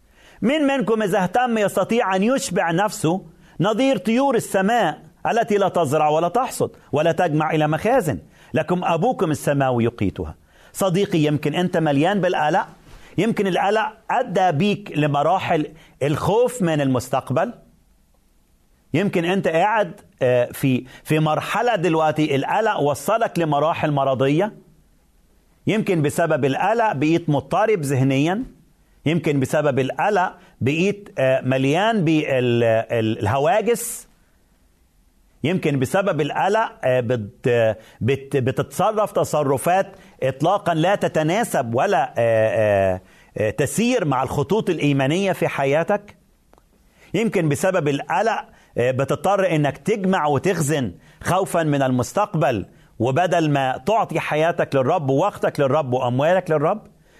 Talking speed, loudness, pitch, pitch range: 100 wpm, -20 LUFS, 160 Hz, 135-195 Hz